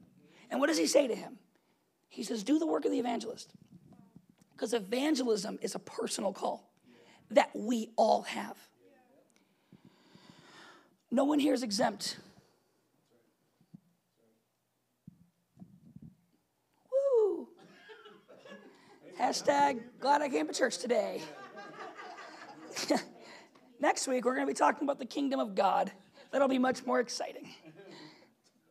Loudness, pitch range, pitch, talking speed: -32 LUFS, 195-285 Hz, 245 Hz, 115 wpm